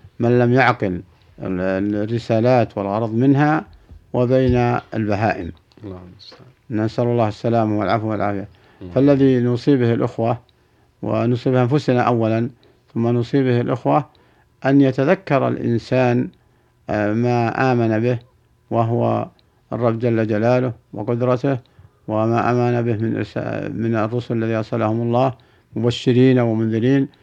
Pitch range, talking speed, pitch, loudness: 110-125 Hz, 95 wpm, 120 Hz, -19 LUFS